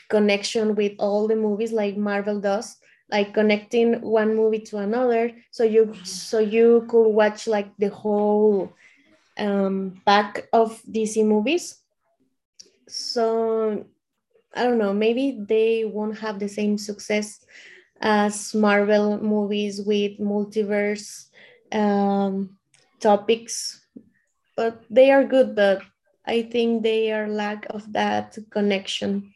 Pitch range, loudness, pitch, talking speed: 205-225 Hz, -22 LUFS, 215 Hz, 120 wpm